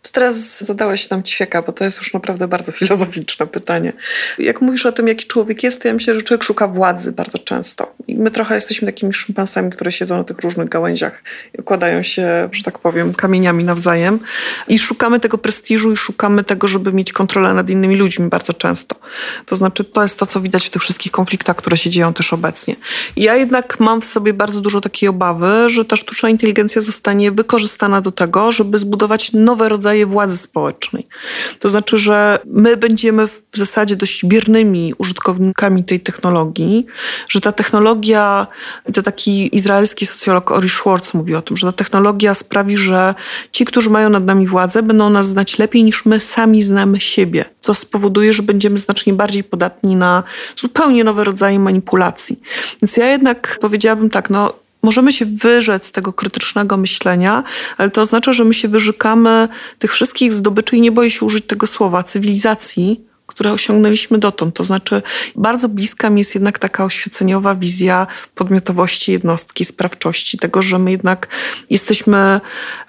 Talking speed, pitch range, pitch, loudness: 175 wpm, 190-220 Hz, 205 Hz, -13 LUFS